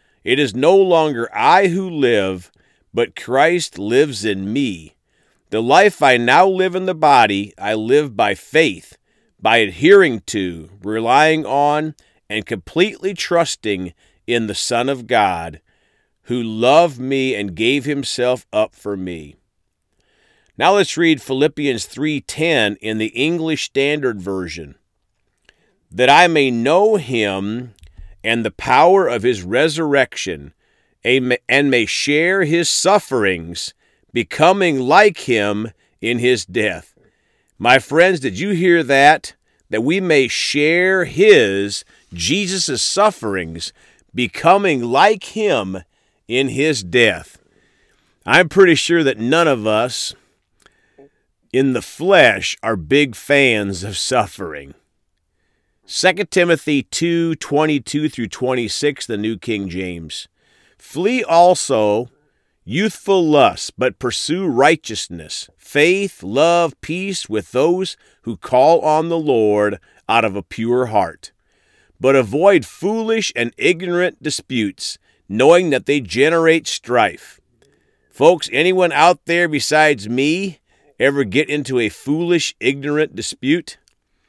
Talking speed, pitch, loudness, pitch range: 120 wpm, 135 Hz, -16 LUFS, 105-170 Hz